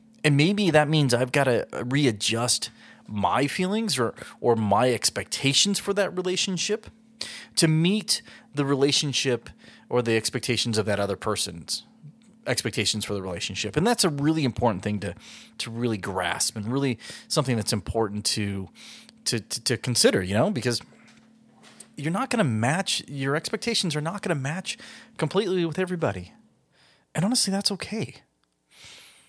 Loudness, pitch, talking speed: -25 LUFS, 140 Hz, 150 wpm